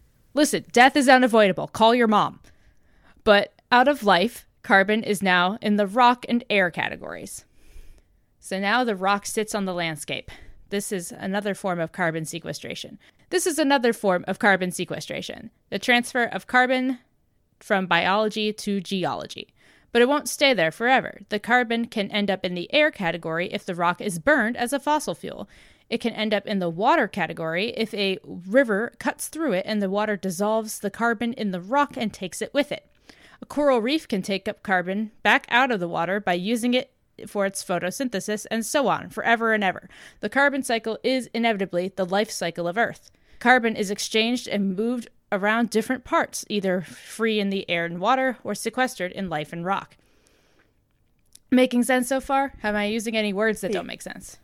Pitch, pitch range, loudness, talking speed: 210 Hz, 190-245 Hz, -23 LUFS, 185 wpm